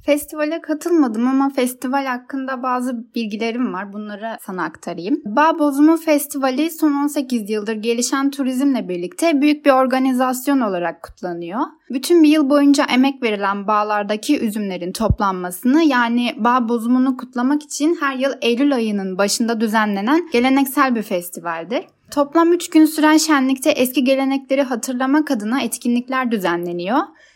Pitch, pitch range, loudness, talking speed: 260 Hz, 230-290 Hz, -18 LUFS, 130 wpm